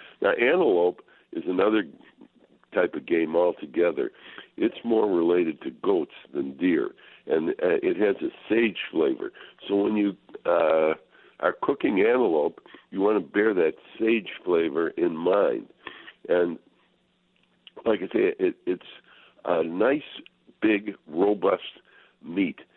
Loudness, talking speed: -25 LUFS, 130 wpm